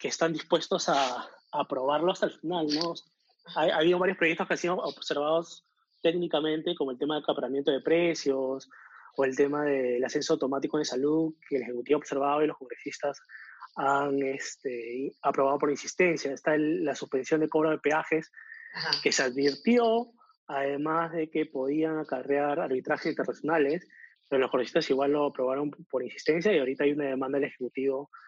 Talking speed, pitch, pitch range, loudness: 170 wpm, 150 Hz, 140-165 Hz, -29 LUFS